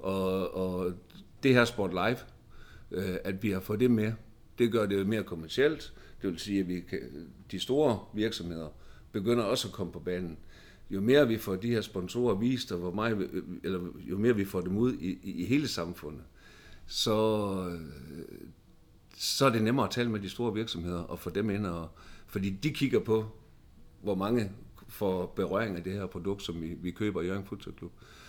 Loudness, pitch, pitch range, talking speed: -31 LUFS, 100 Hz, 90-110 Hz, 195 wpm